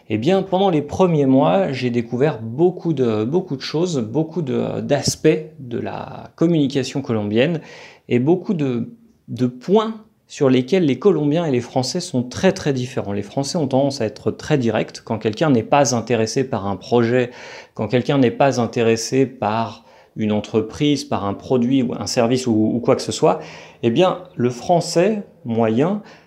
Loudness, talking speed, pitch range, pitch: -19 LUFS, 175 wpm, 120-165 Hz, 130 Hz